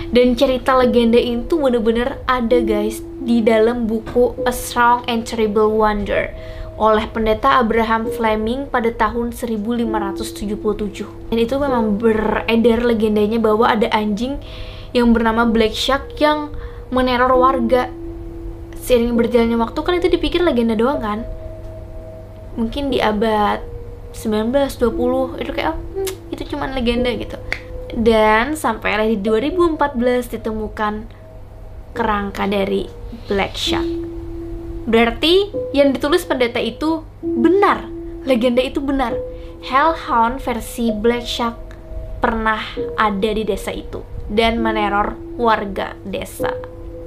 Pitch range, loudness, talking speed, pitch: 205-250 Hz, -18 LUFS, 110 wpm, 230 Hz